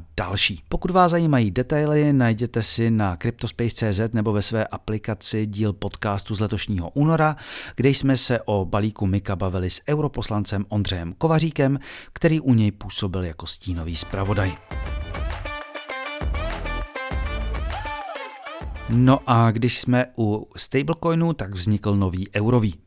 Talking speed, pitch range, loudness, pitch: 120 wpm, 100-135 Hz, -23 LUFS, 110 Hz